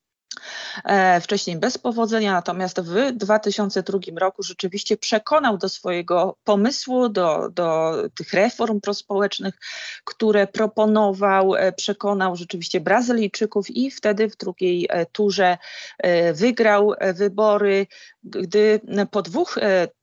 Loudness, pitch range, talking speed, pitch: -21 LUFS, 190-220 Hz, 95 wpm, 205 Hz